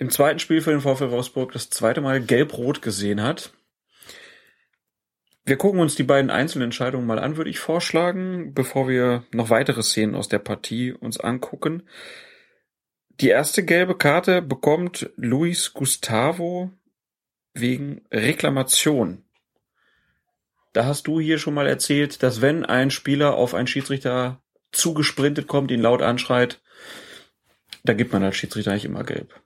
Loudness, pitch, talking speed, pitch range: -21 LUFS, 140 Hz, 145 wpm, 125-160 Hz